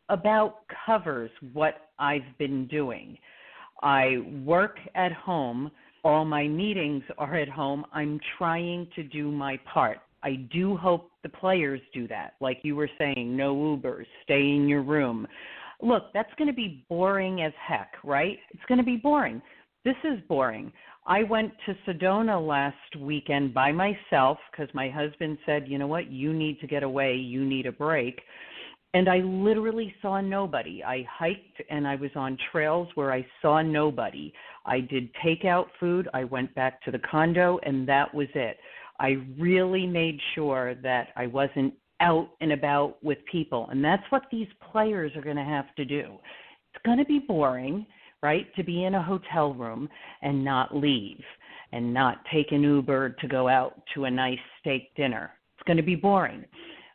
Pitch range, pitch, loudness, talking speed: 135-180 Hz, 150 Hz, -27 LUFS, 175 wpm